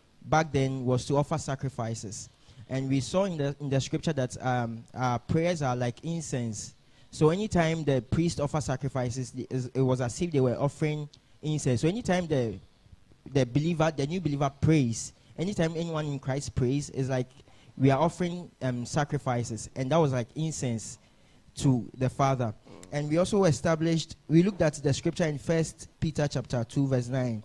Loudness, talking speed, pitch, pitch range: -29 LUFS, 175 wpm, 135 Hz, 125-155 Hz